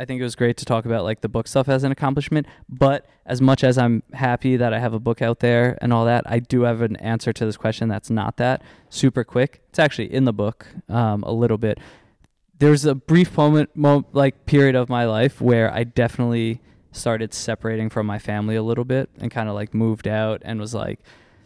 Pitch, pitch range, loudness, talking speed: 120 Hz, 110-130 Hz, -20 LUFS, 230 wpm